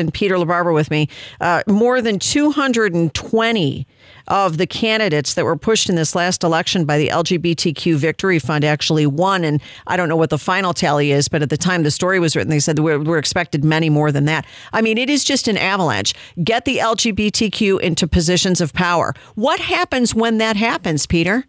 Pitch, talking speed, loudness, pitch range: 175 Hz, 200 wpm, -16 LUFS, 155-220 Hz